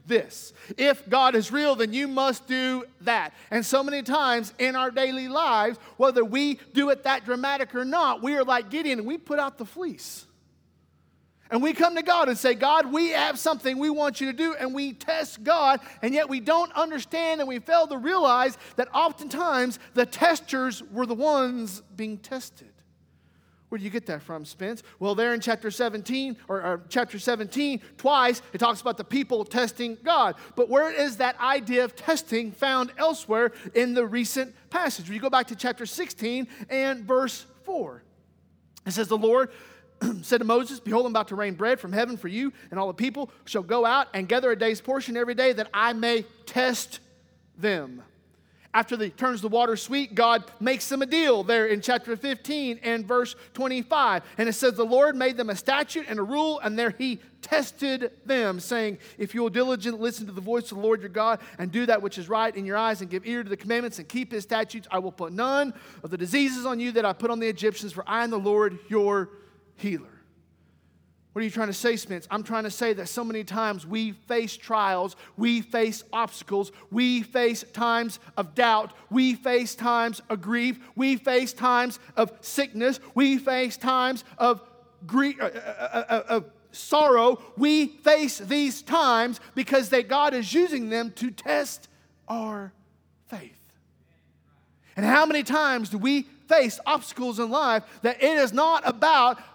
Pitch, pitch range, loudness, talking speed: 240 Hz, 215-265 Hz, -25 LUFS, 195 wpm